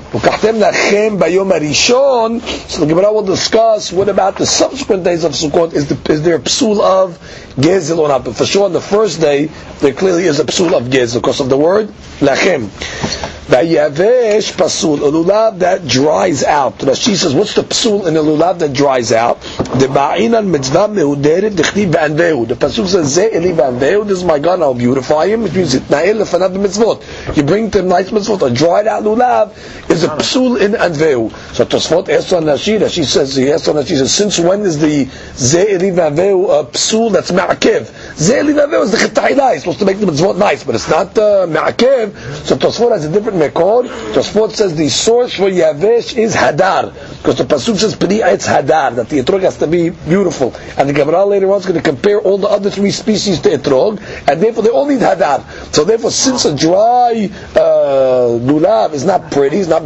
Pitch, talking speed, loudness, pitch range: 195 Hz, 170 wpm, -12 LUFS, 155-220 Hz